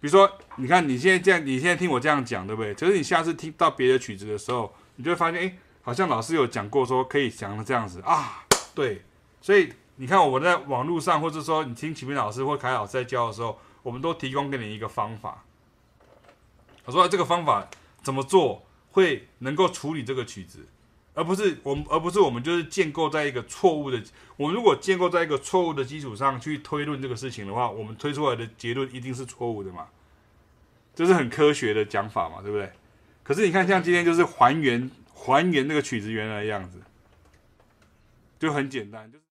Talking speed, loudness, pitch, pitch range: 325 characters per minute, -25 LUFS, 135 Hz, 110-160 Hz